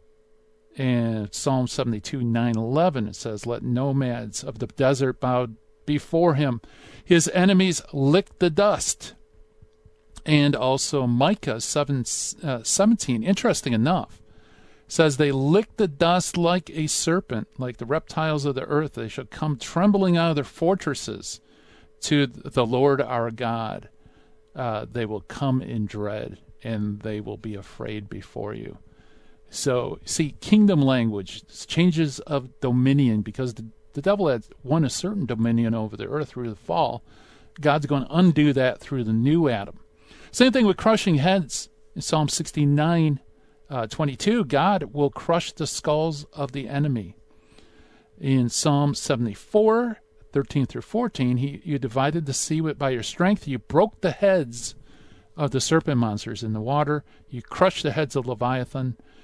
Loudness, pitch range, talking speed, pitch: -23 LUFS, 120-160 Hz, 150 wpm, 140 Hz